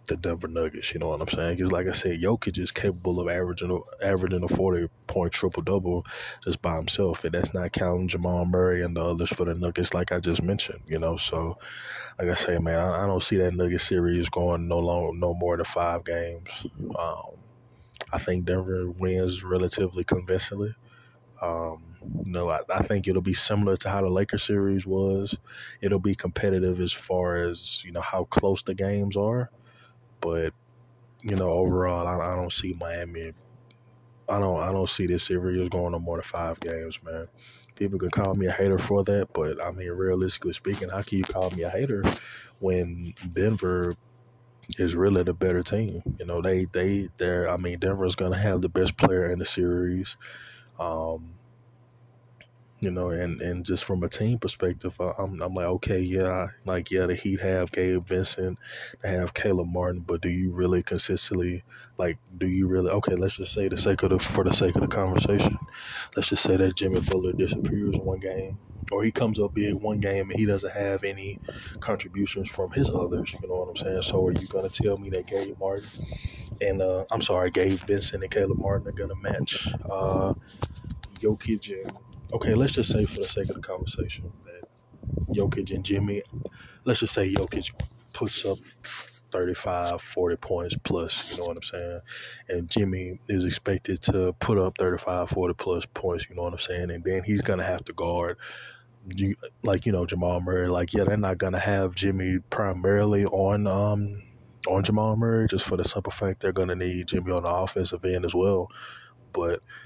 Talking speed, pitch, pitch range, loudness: 195 wpm, 95 Hz, 90-100 Hz, -27 LUFS